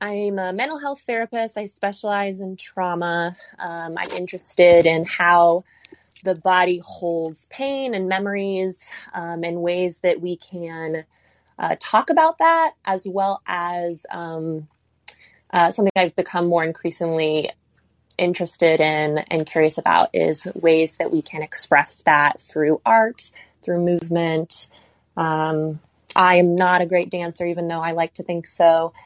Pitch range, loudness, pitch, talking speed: 165-190 Hz, -20 LUFS, 175 Hz, 145 wpm